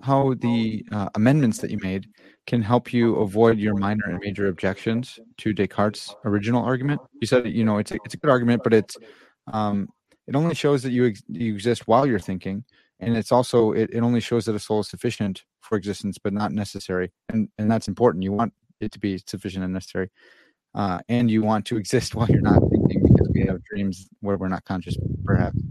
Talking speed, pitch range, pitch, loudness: 215 wpm, 100-120 Hz, 110 Hz, -23 LUFS